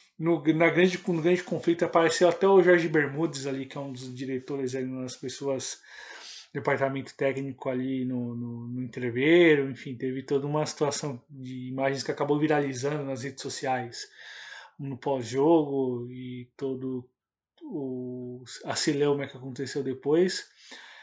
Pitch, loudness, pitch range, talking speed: 135 Hz, -27 LUFS, 130-155 Hz, 140 wpm